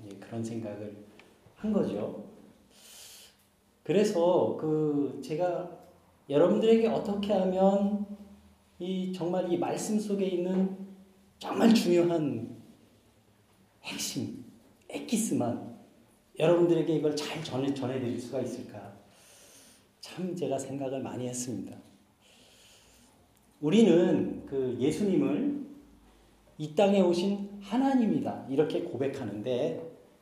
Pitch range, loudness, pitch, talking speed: 125-200 Hz, -29 LUFS, 170 Hz, 205 characters per minute